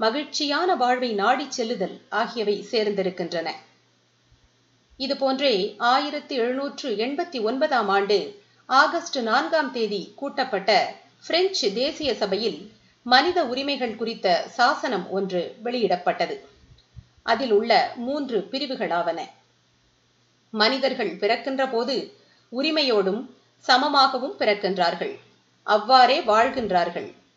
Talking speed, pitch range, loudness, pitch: 80 wpm, 205-280 Hz, -23 LUFS, 245 Hz